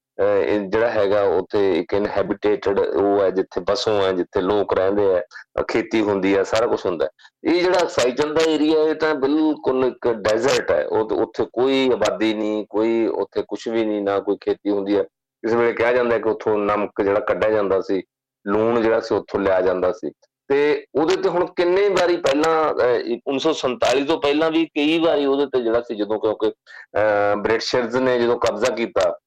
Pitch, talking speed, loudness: 135 Hz, 185 wpm, -20 LUFS